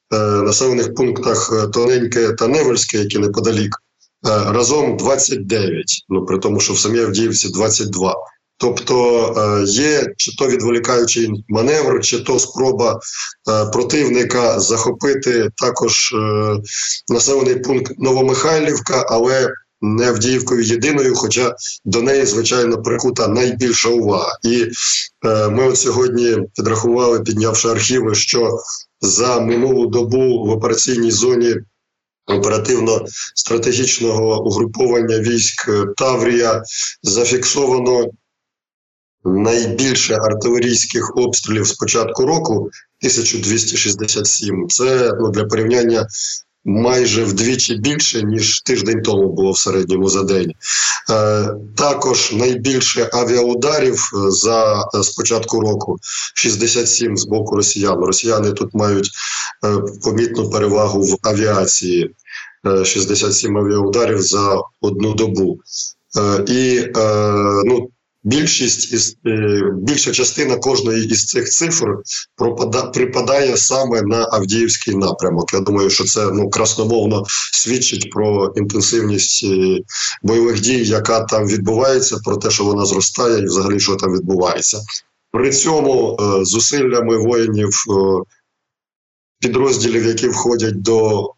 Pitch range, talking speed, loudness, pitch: 105-120 Hz, 100 wpm, -15 LUFS, 110 Hz